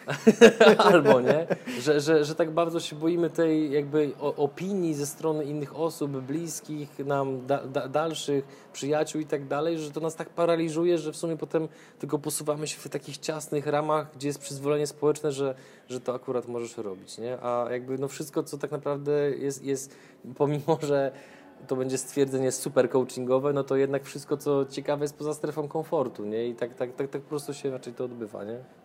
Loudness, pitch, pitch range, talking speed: -27 LUFS, 145 Hz, 135-155 Hz, 185 wpm